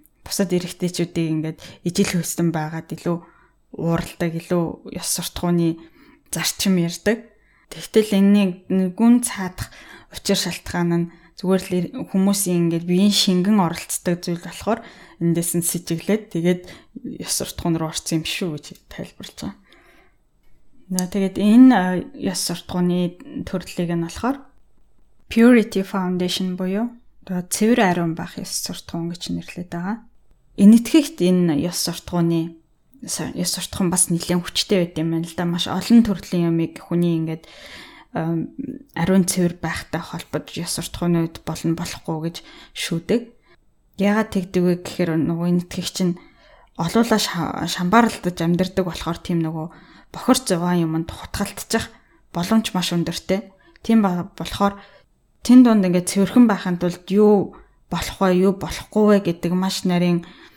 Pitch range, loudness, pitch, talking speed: 170-200 Hz, -20 LUFS, 180 Hz, 130 wpm